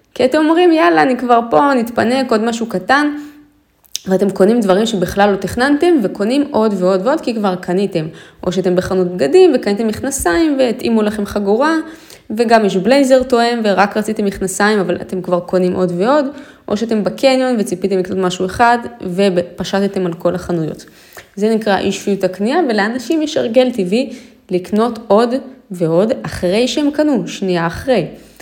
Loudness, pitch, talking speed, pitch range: -14 LUFS, 215 Hz, 155 wpm, 190-255 Hz